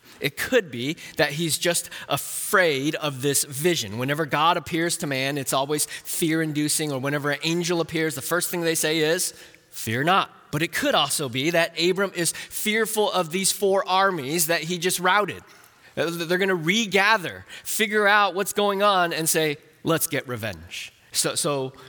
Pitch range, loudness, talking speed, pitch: 145-185 Hz, -23 LUFS, 180 wpm, 165 Hz